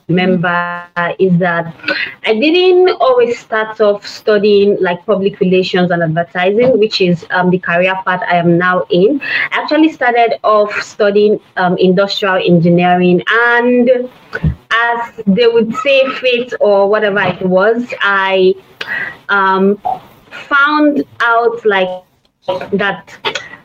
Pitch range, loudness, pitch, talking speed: 180-235 Hz, -12 LUFS, 200 Hz, 125 wpm